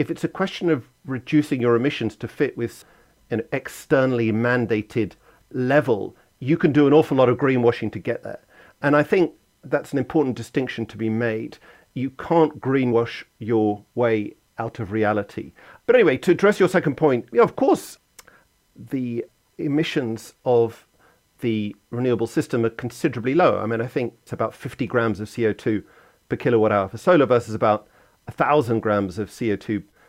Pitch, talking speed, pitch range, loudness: 120 Hz, 175 wpm, 115-145 Hz, -22 LUFS